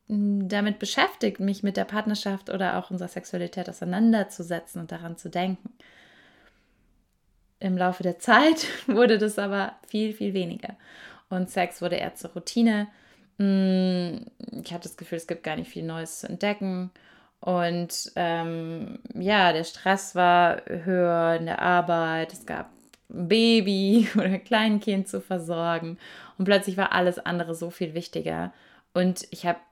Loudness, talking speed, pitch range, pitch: -25 LUFS, 145 wpm, 175-210 Hz, 185 Hz